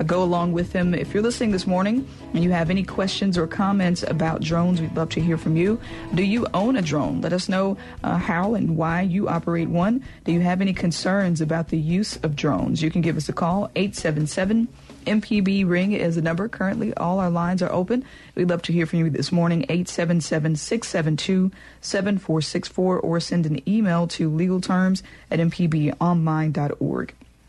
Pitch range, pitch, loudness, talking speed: 165-195 Hz, 175 Hz, -23 LUFS, 185 wpm